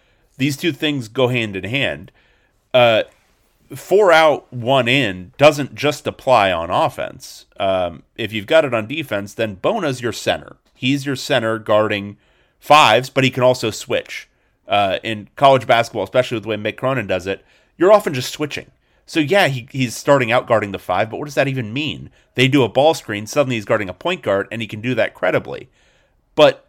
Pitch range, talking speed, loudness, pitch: 110-140 Hz, 195 wpm, -17 LUFS, 125 Hz